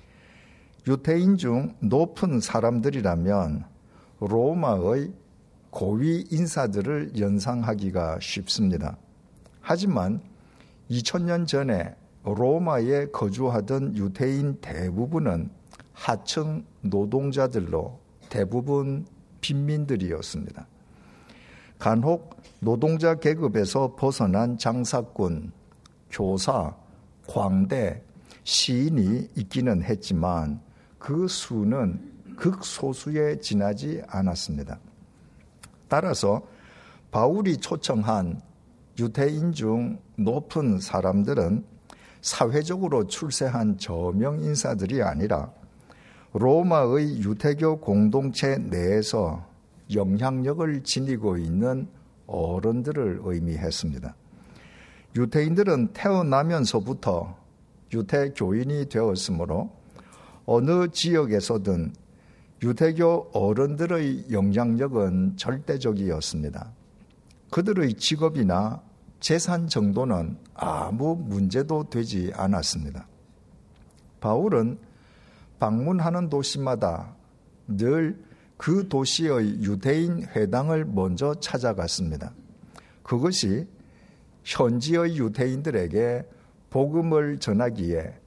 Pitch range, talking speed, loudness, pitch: 100-150 Hz, 205 characters per minute, -25 LUFS, 125 Hz